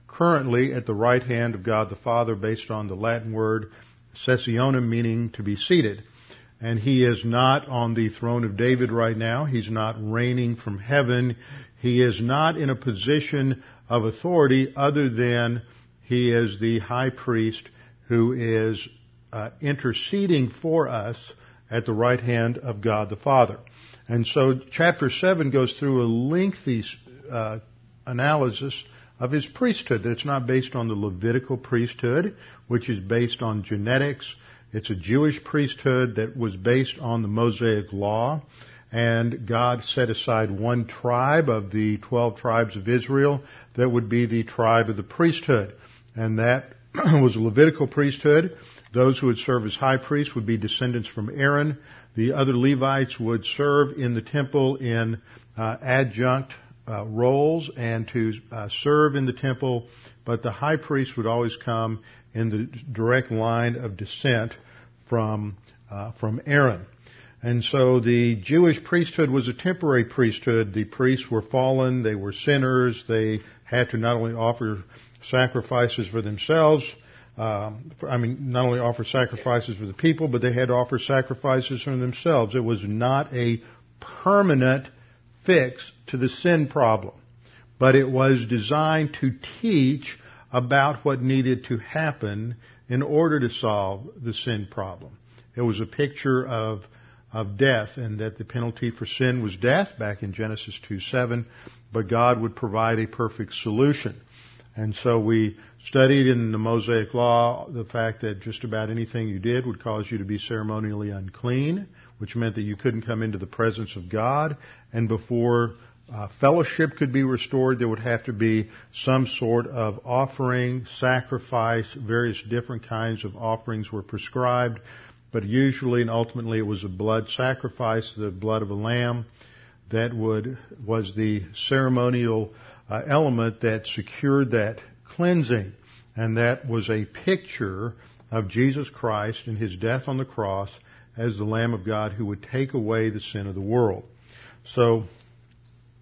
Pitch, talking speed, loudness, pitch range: 120 Hz, 160 wpm, -24 LUFS, 115-130 Hz